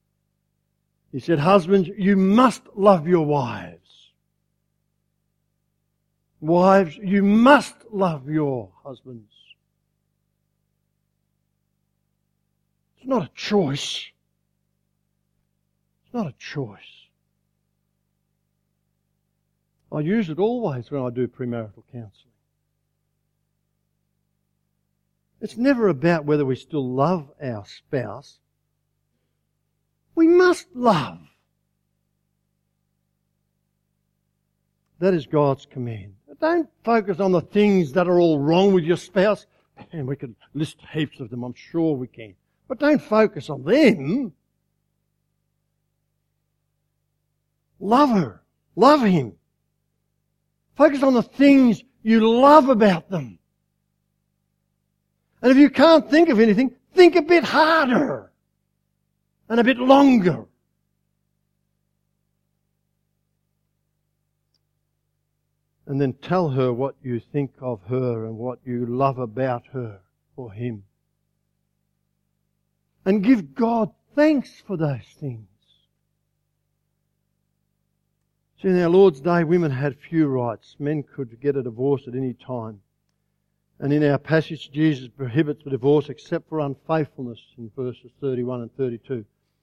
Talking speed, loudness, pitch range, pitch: 105 wpm, -20 LUFS, 135-190 Hz, 150 Hz